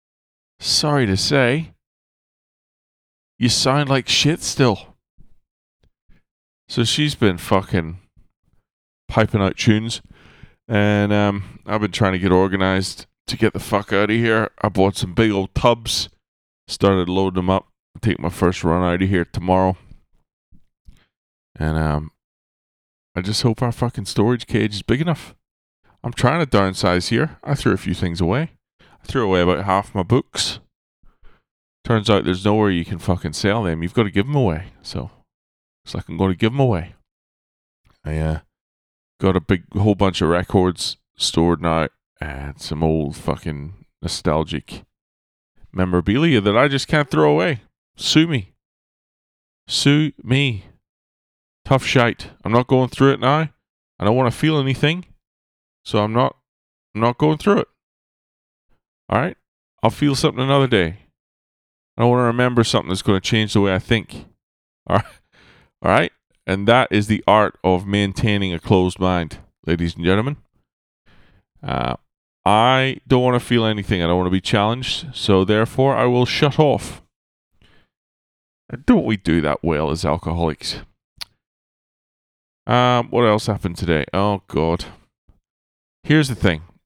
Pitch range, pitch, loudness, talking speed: 85-120 Hz, 100 Hz, -19 LUFS, 155 wpm